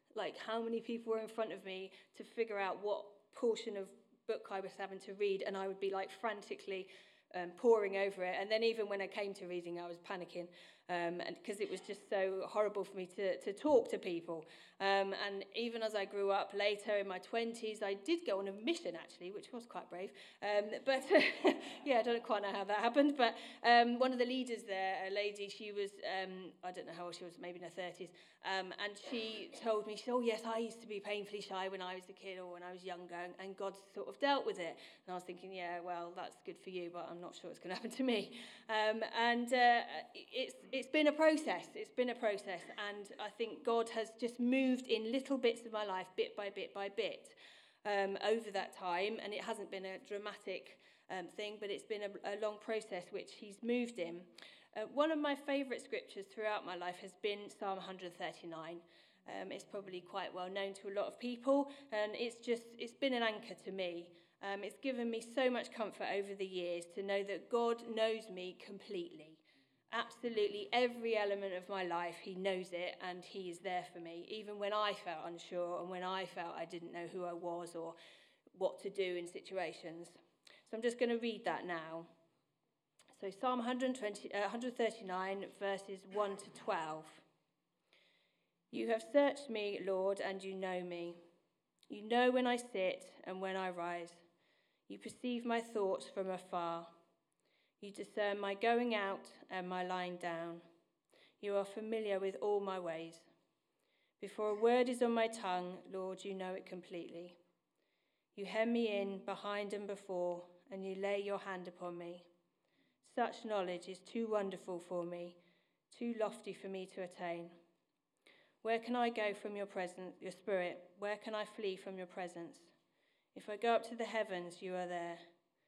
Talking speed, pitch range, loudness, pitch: 200 wpm, 180-225 Hz, -40 LUFS, 200 Hz